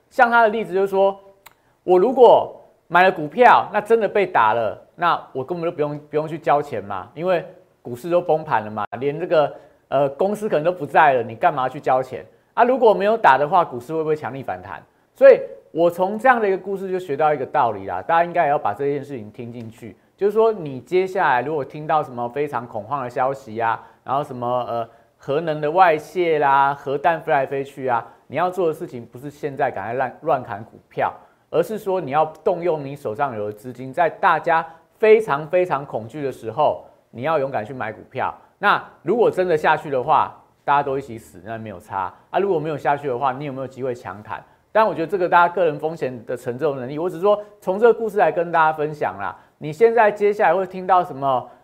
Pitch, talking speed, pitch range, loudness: 155 Hz, 325 characters per minute, 135-185 Hz, -20 LUFS